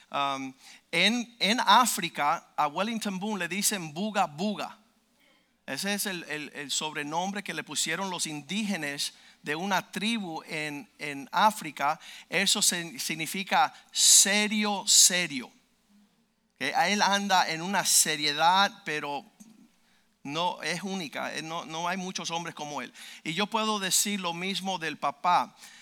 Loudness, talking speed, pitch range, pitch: -26 LUFS, 130 wpm, 160-215 Hz, 190 Hz